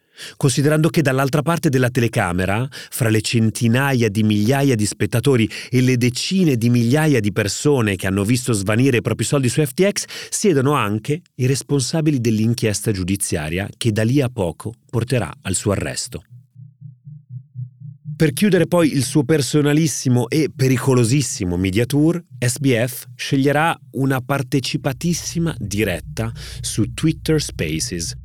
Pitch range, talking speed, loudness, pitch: 115-145 Hz, 130 wpm, -19 LUFS, 130 Hz